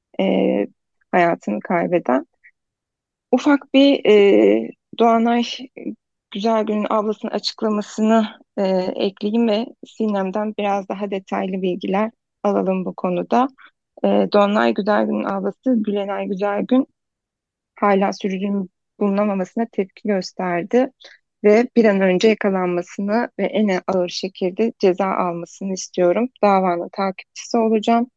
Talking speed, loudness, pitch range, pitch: 100 wpm, -19 LUFS, 190-225 Hz, 205 Hz